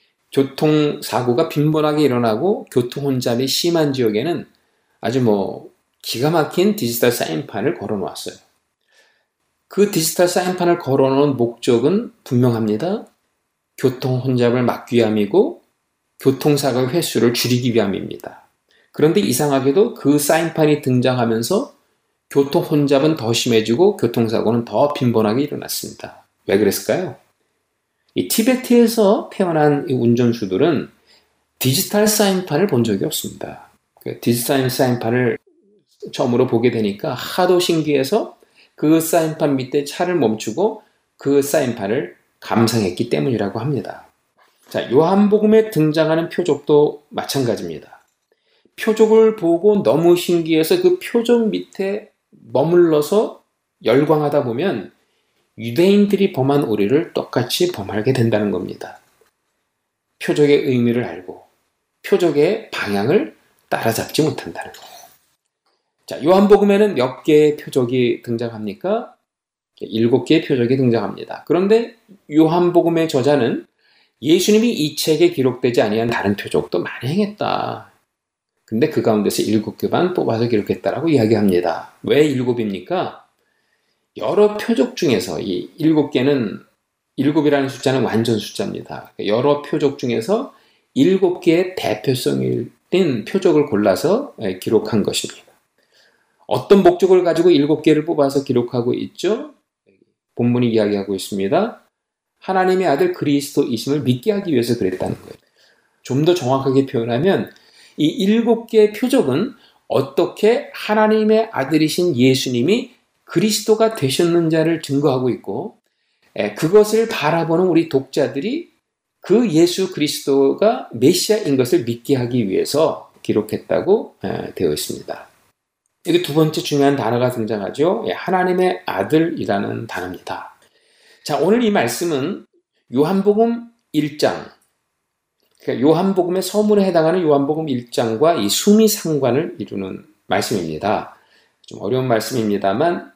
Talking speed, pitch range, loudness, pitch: 295 characters per minute, 125-185 Hz, -17 LUFS, 150 Hz